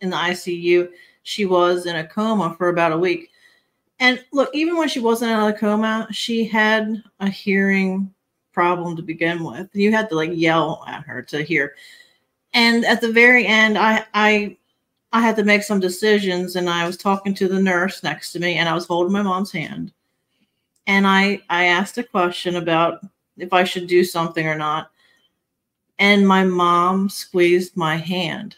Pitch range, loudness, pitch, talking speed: 175-215 Hz, -18 LUFS, 190 Hz, 185 wpm